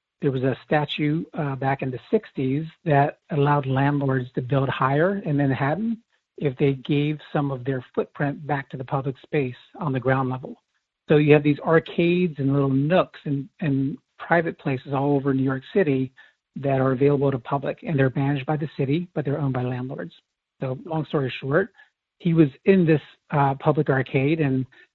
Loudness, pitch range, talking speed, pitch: -23 LUFS, 135-155 Hz, 190 wpm, 140 Hz